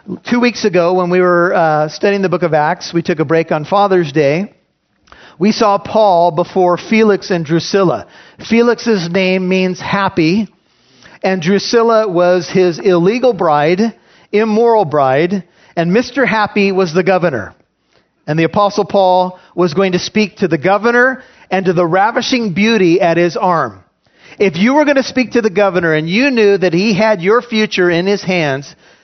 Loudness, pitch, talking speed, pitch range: -13 LUFS, 190 Hz, 170 wpm, 175-215 Hz